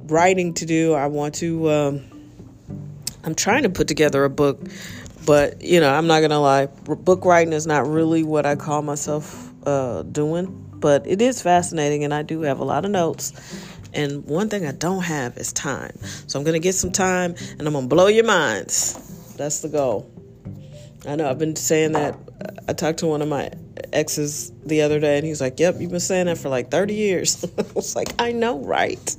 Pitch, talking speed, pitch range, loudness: 155 Hz, 210 wpm, 145-175 Hz, -20 LUFS